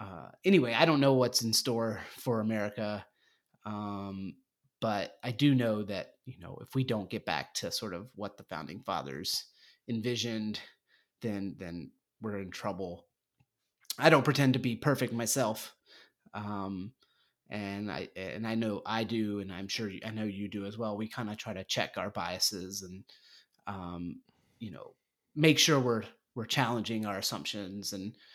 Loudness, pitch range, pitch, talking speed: -32 LUFS, 100-120 Hz, 110 Hz, 170 wpm